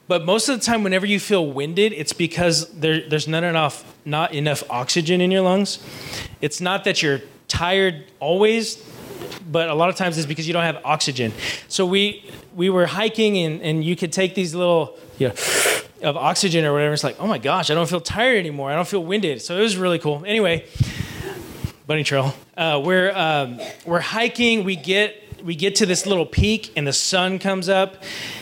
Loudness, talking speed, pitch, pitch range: -20 LUFS, 205 wpm, 175 Hz, 150-195 Hz